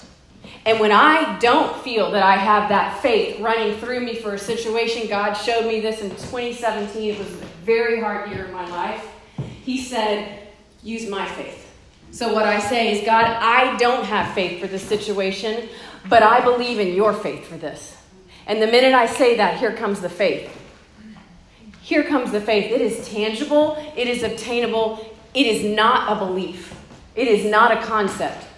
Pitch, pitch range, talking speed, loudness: 220 Hz, 210-235 Hz, 185 wpm, -19 LUFS